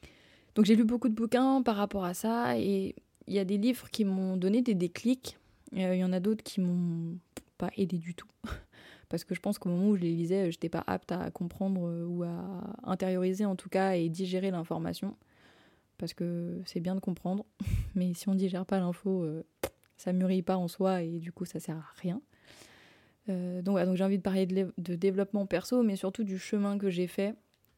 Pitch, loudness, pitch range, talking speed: 190 Hz, -32 LUFS, 180-200 Hz, 225 wpm